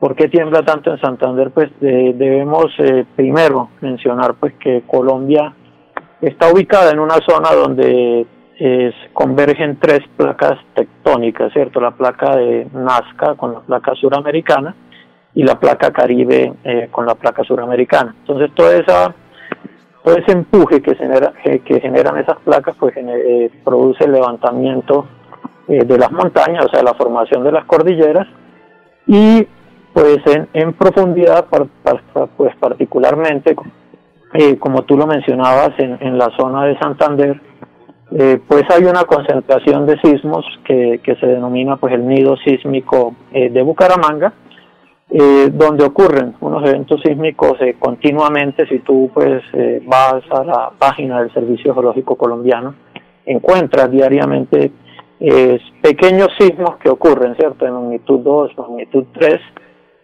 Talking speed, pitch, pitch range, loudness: 135 wpm, 135 Hz, 125-150 Hz, -12 LUFS